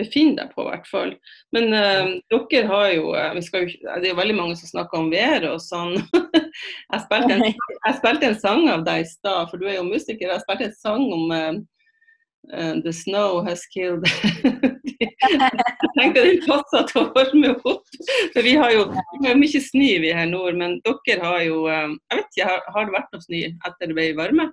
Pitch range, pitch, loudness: 175-275 Hz, 215 Hz, -20 LUFS